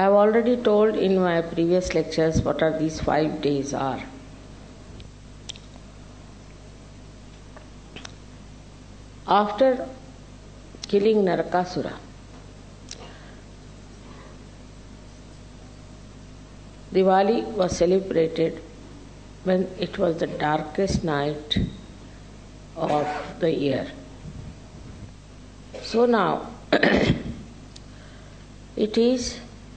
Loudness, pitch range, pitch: -23 LUFS, 115-175 Hz, 130 Hz